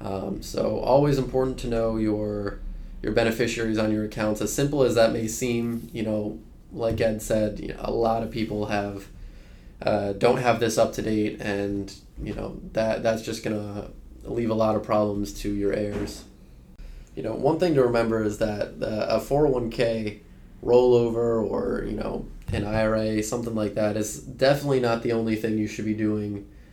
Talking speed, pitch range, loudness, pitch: 185 wpm, 105-115 Hz, -25 LUFS, 110 Hz